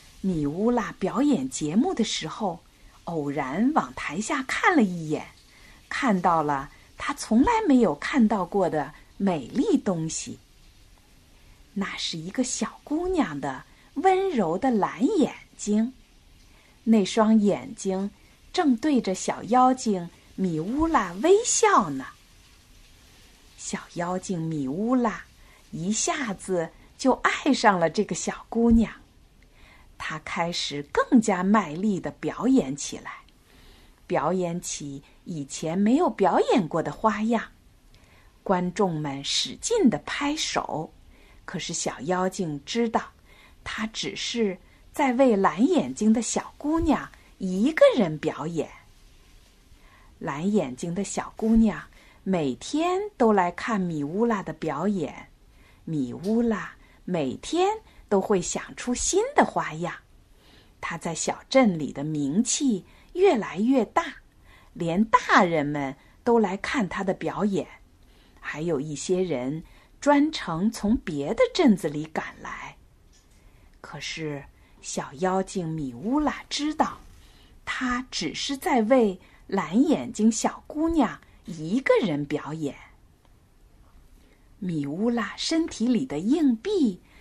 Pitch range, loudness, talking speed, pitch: 170-255 Hz, -25 LUFS, 170 characters per minute, 210 Hz